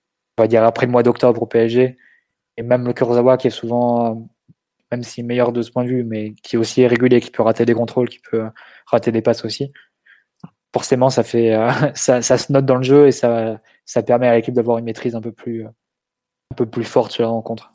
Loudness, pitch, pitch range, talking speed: -17 LUFS, 120 Hz, 115-125 Hz, 235 wpm